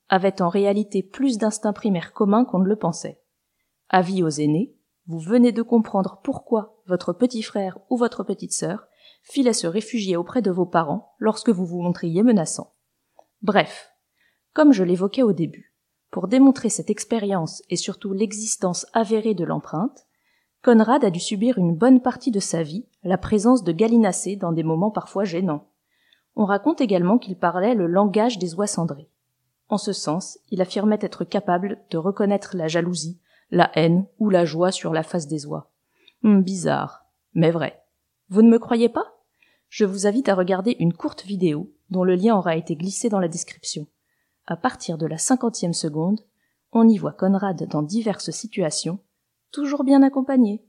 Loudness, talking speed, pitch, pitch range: -21 LUFS, 175 wpm, 200 Hz, 175-225 Hz